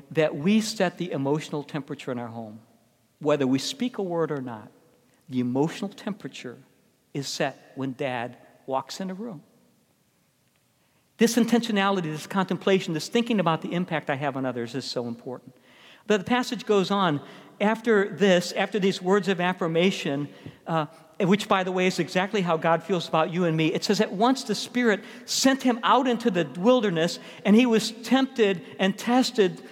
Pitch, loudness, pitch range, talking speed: 185 Hz, -25 LUFS, 150-215 Hz, 175 wpm